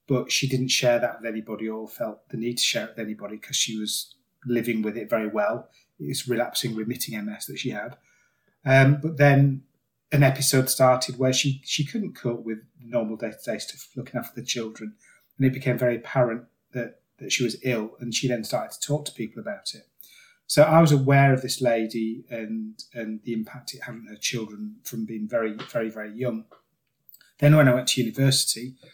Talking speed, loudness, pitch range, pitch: 210 wpm, -24 LUFS, 110-135 Hz, 120 Hz